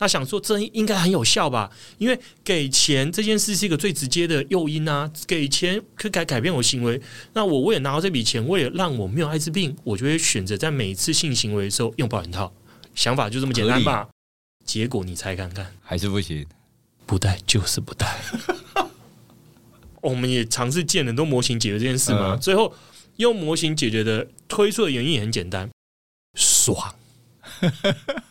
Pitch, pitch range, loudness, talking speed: 130 Hz, 110-170 Hz, -22 LUFS, 280 characters per minute